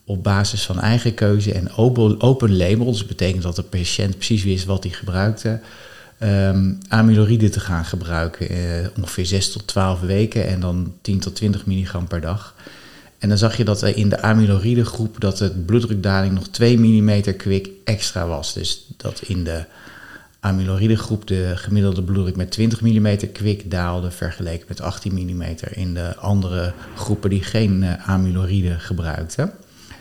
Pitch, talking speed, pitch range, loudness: 100 Hz, 170 wpm, 90-105 Hz, -20 LUFS